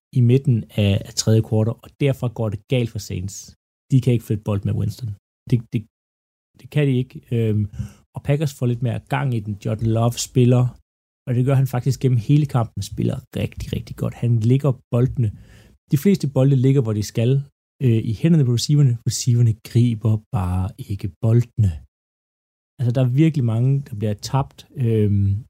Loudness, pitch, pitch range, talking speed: -20 LUFS, 120 Hz, 105-130 Hz, 175 wpm